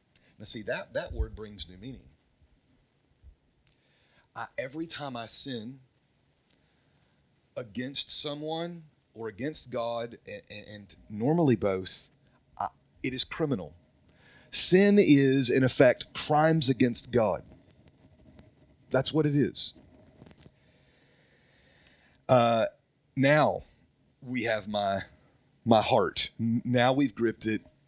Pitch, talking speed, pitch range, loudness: 125 Hz, 105 wpm, 105-140 Hz, -27 LUFS